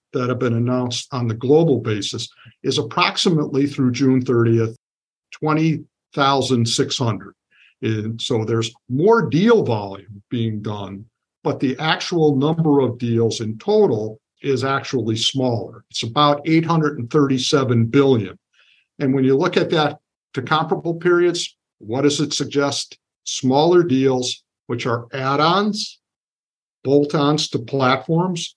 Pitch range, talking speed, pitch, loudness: 115-150 Hz, 125 wpm, 135 Hz, -19 LUFS